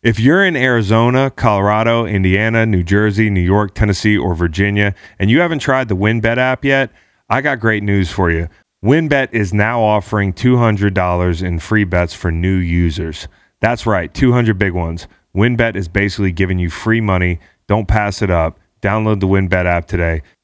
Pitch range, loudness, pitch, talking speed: 90-115 Hz, -15 LUFS, 100 Hz, 175 wpm